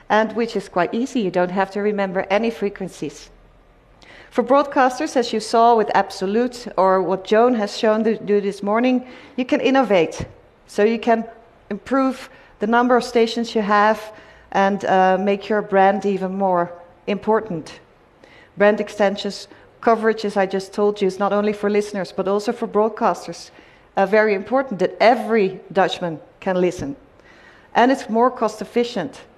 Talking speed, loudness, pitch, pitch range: 160 wpm, -19 LUFS, 210 Hz, 195-230 Hz